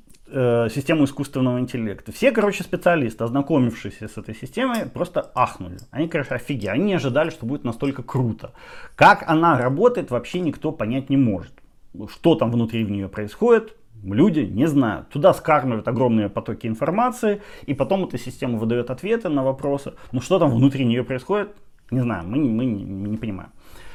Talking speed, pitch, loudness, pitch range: 170 wpm, 130 Hz, -21 LUFS, 115-160 Hz